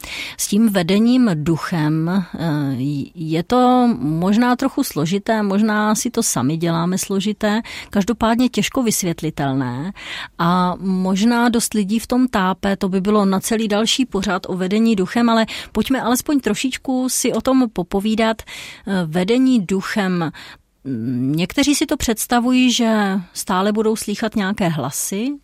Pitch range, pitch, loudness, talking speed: 180-235 Hz, 210 Hz, -18 LUFS, 130 wpm